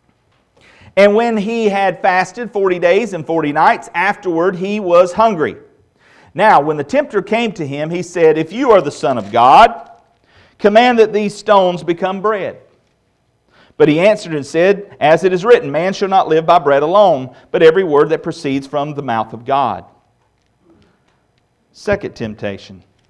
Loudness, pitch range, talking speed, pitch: -13 LUFS, 150-210 Hz, 165 wpm, 185 Hz